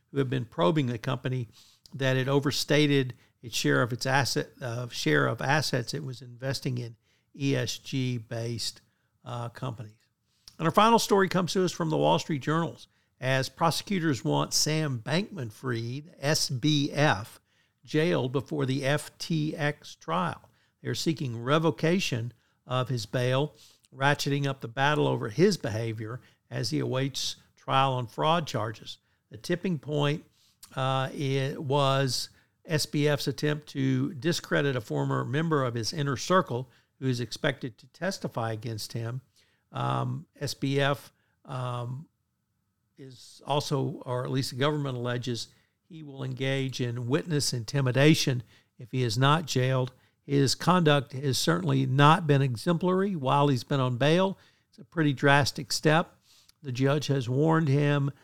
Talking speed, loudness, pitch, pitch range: 140 wpm, -28 LUFS, 135 Hz, 120-150 Hz